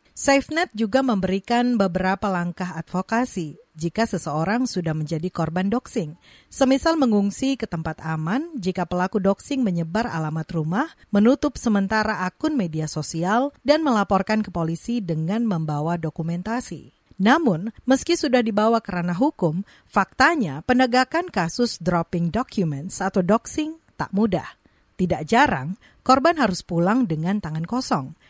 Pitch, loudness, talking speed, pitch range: 200 Hz, -22 LUFS, 125 wpm, 170-245 Hz